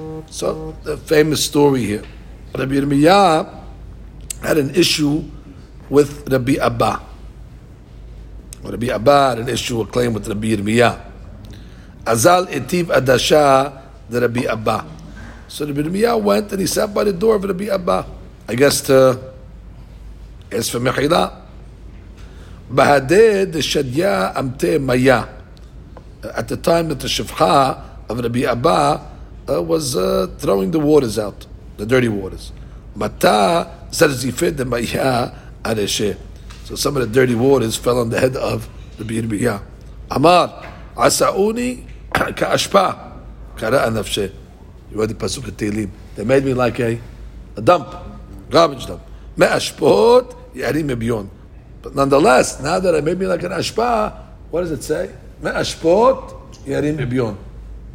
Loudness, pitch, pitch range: -17 LUFS, 130 Hz, 110-150 Hz